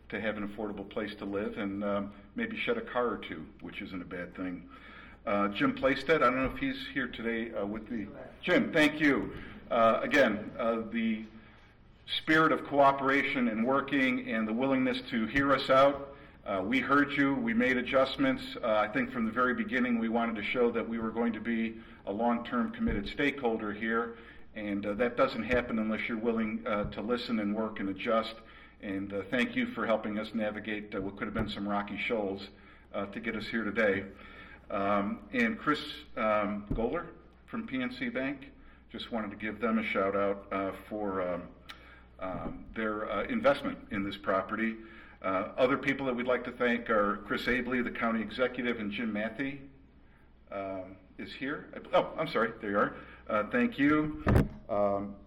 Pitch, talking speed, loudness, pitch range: 115 Hz, 190 wpm, -31 LUFS, 105-135 Hz